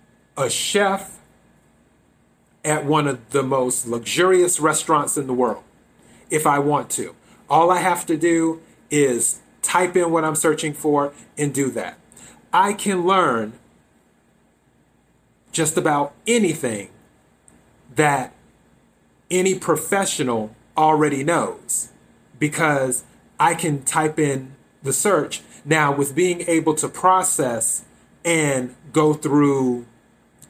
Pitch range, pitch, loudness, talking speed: 140-170 Hz, 155 Hz, -20 LUFS, 115 wpm